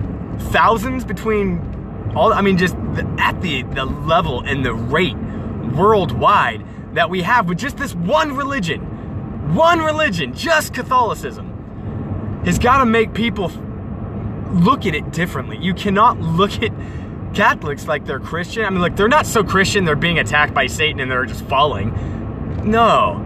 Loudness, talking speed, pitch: -17 LUFS, 155 wpm, 185 Hz